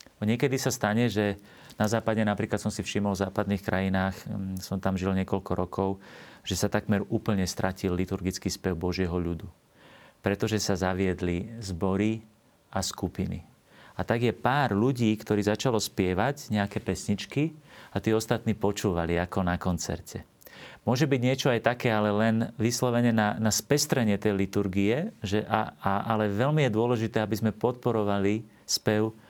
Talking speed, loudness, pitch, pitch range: 150 wpm, -28 LUFS, 105 Hz, 95-115 Hz